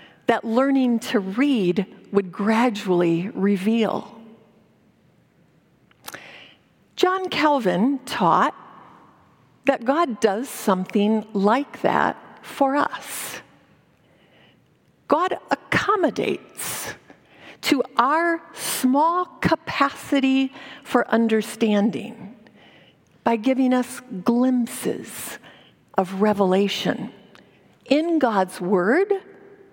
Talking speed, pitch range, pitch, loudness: 70 wpm, 210-275 Hz, 235 Hz, -22 LUFS